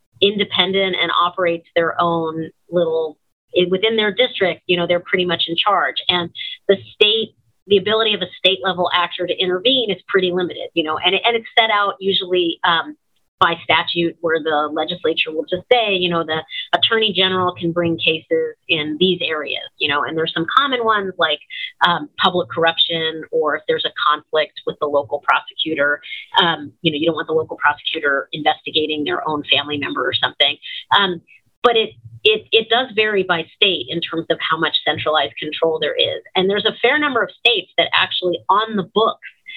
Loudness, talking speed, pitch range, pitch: -17 LUFS, 190 wpm, 160-210 Hz, 180 Hz